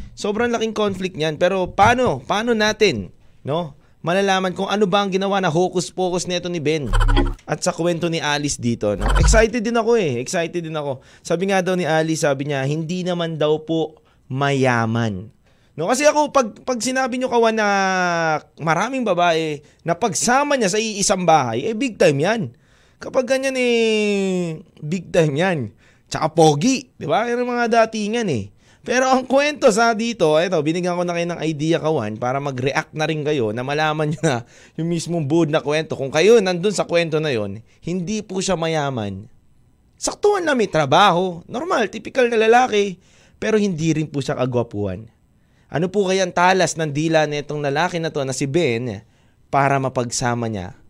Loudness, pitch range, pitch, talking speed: -19 LUFS, 145-205 Hz, 170 Hz, 175 wpm